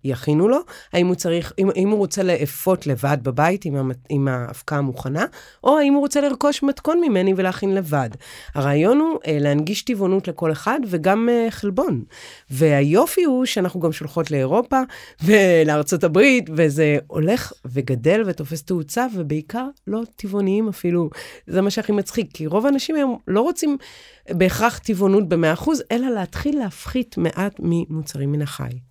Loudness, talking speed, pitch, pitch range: -20 LUFS, 145 wpm, 185 Hz, 155-235 Hz